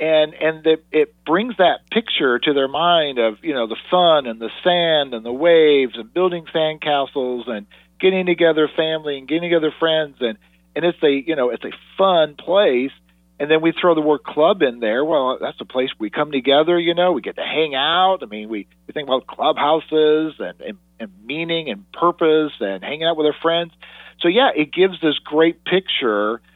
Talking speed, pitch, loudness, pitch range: 210 wpm, 155 Hz, -18 LUFS, 130-170 Hz